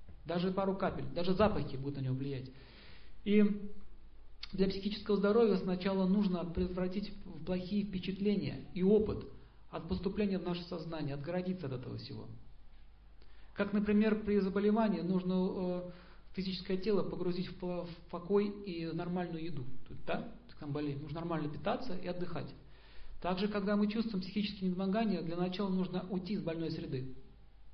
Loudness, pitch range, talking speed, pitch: -36 LUFS, 165-200 Hz, 140 wpm, 185 Hz